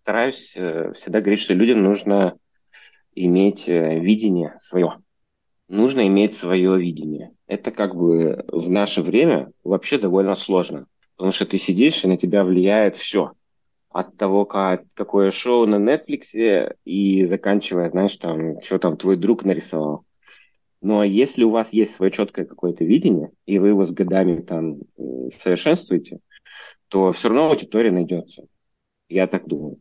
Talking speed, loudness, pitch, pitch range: 140 wpm, -19 LUFS, 95 Hz, 90-100 Hz